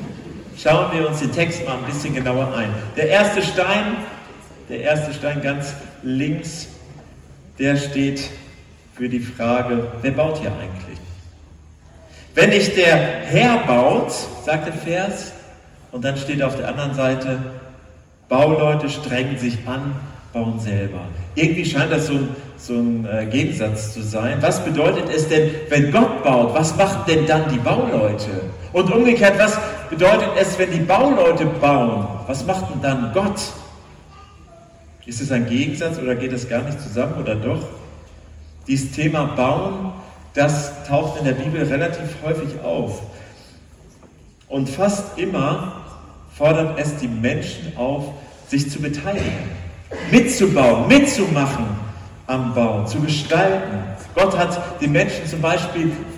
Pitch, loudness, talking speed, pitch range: 140 Hz, -19 LUFS, 140 wpm, 115-160 Hz